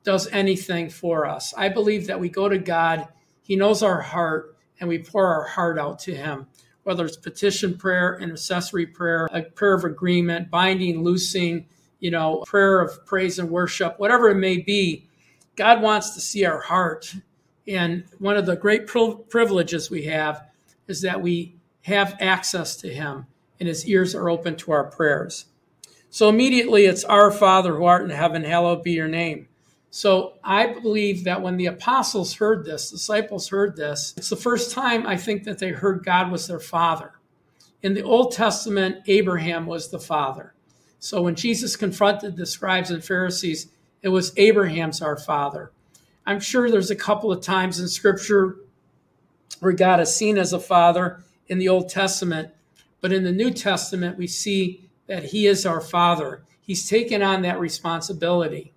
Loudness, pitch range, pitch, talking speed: -21 LUFS, 170-200 Hz, 180 Hz, 175 wpm